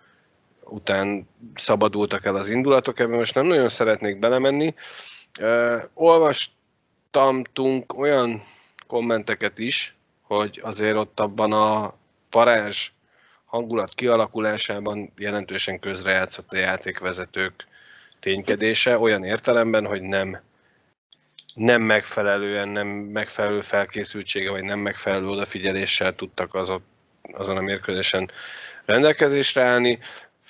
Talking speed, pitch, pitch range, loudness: 90 wpm, 105 Hz, 100-120 Hz, -22 LUFS